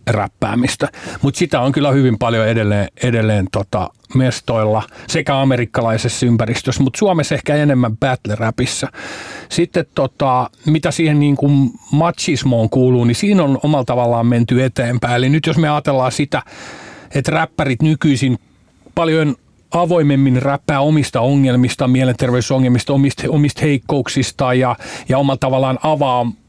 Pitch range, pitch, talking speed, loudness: 120-150 Hz, 135 Hz, 130 wpm, -15 LUFS